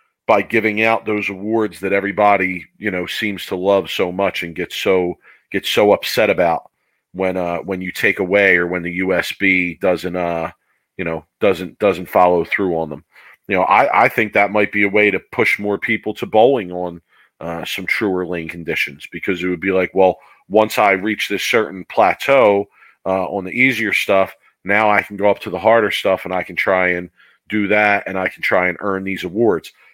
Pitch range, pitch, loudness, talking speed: 90-105 Hz, 95 Hz, -17 LUFS, 210 wpm